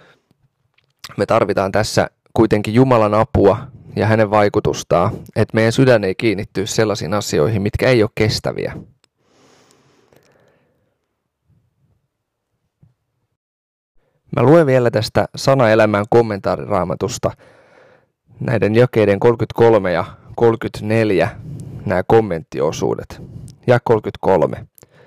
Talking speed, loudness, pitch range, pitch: 85 wpm, -16 LUFS, 105-125 Hz, 115 Hz